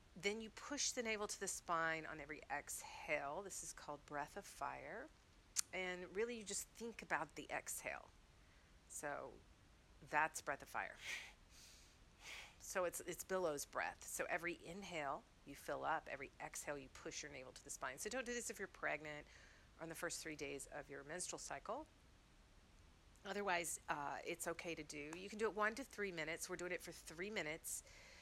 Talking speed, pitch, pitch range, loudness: 185 wpm, 175 Hz, 150-205 Hz, -46 LUFS